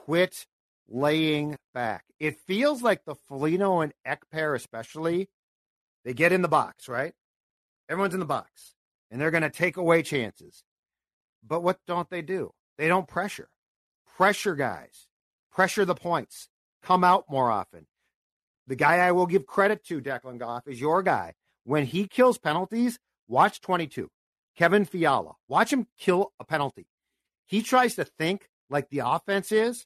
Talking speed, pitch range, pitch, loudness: 160 wpm, 150-195 Hz, 175 Hz, -26 LUFS